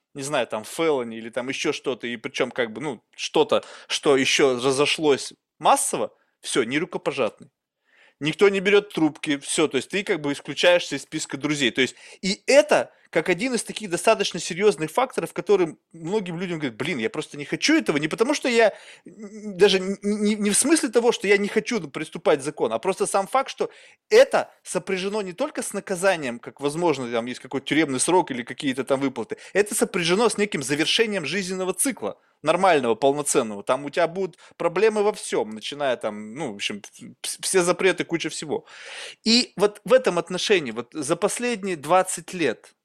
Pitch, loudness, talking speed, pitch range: 185 Hz, -23 LUFS, 185 wpm, 145-215 Hz